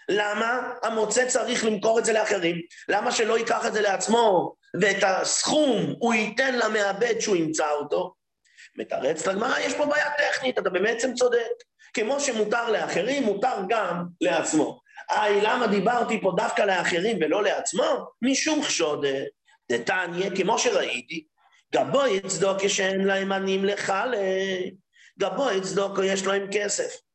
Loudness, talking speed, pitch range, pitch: -24 LUFS, 135 wpm, 195-260 Hz, 220 Hz